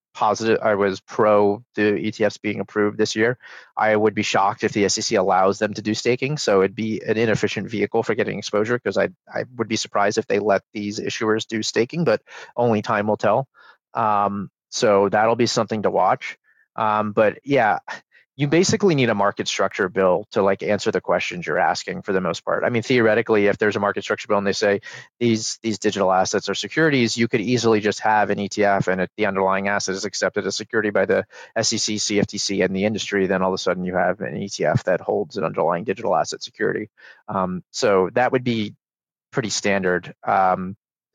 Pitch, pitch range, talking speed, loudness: 105 Hz, 100-115 Hz, 205 wpm, -21 LUFS